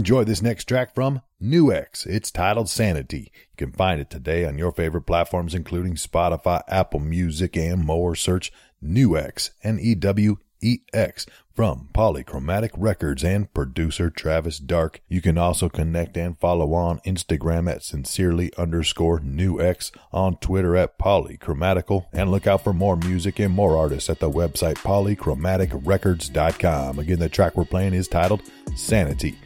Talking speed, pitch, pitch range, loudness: 145 wpm, 90 Hz, 80-95 Hz, -22 LUFS